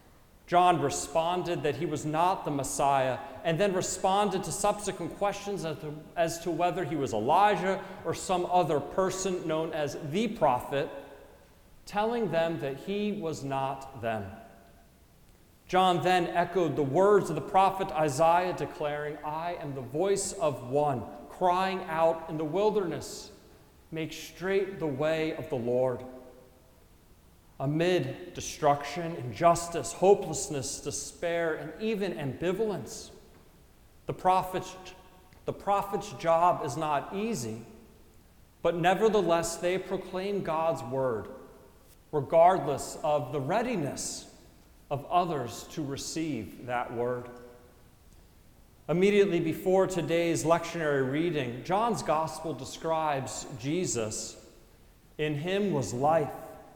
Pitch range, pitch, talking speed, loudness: 140-185 Hz, 160 Hz, 115 wpm, -29 LUFS